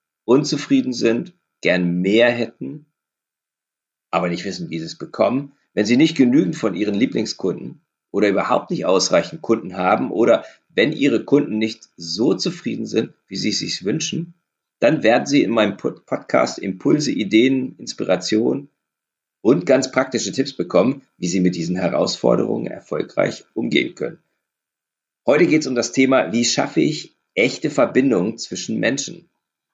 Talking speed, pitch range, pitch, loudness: 145 wpm, 85-135 Hz, 110 Hz, -19 LUFS